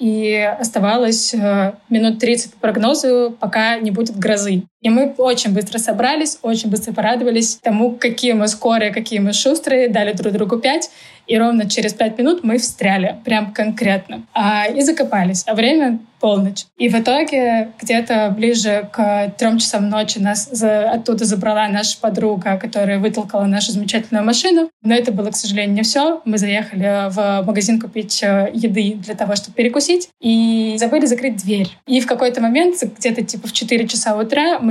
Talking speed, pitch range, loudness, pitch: 165 wpm, 210-240 Hz, -16 LUFS, 225 Hz